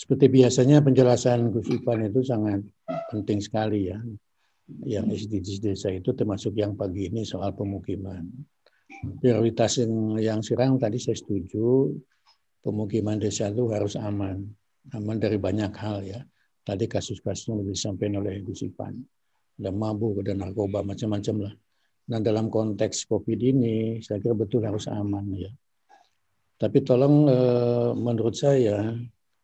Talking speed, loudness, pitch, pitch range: 130 wpm, -25 LUFS, 110 Hz, 100-120 Hz